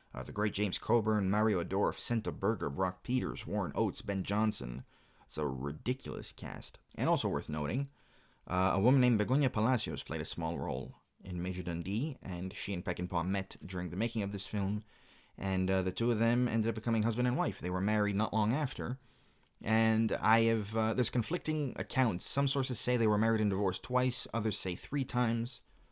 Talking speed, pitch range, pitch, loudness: 195 wpm, 95-125 Hz, 110 Hz, -33 LUFS